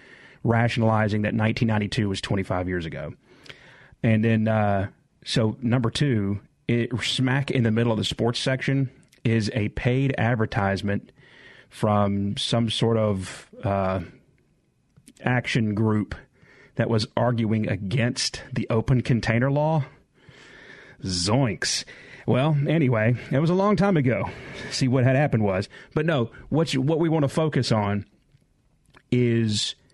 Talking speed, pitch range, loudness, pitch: 130 wpm, 110-135 Hz, -24 LUFS, 115 Hz